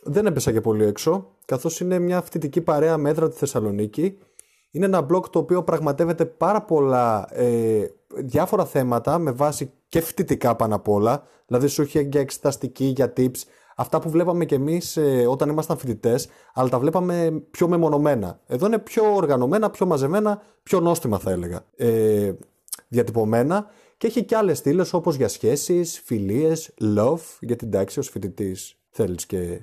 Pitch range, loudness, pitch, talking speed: 120-175 Hz, -22 LUFS, 150 Hz, 175 wpm